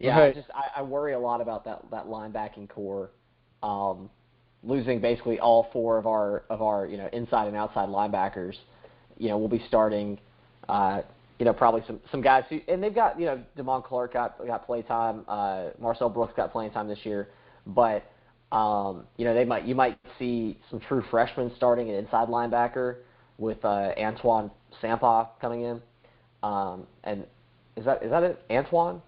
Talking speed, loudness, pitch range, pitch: 185 wpm, -27 LUFS, 105-125 Hz, 115 Hz